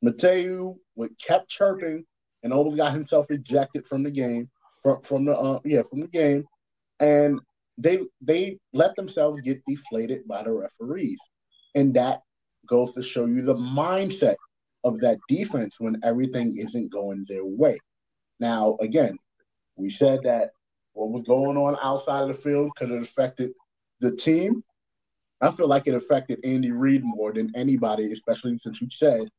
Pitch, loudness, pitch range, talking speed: 135 Hz, -25 LUFS, 120-150 Hz, 160 wpm